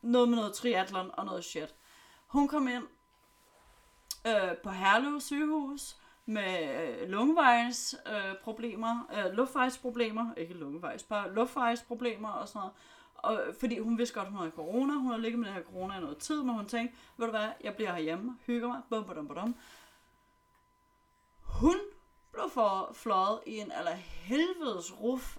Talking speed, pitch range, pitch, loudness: 160 wpm, 205-255 Hz, 235 Hz, -33 LUFS